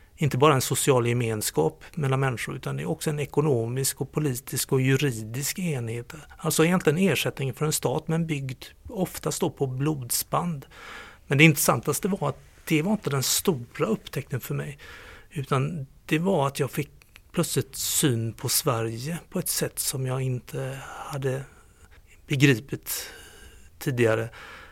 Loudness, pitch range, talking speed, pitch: -26 LUFS, 130-155 Hz, 150 wpm, 140 Hz